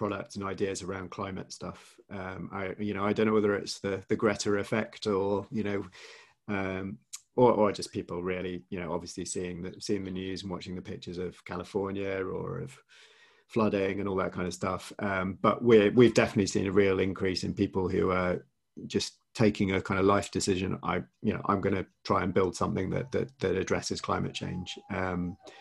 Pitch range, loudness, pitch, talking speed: 95-100 Hz, -30 LUFS, 95 Hz, 205 wpm